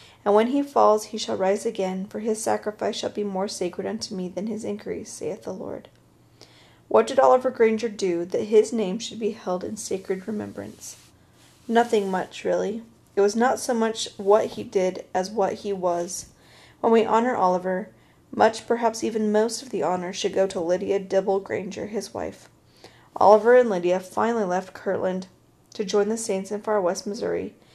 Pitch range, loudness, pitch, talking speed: 190-220 Hz, -24 LUFS, 205 Hz, 185 wpm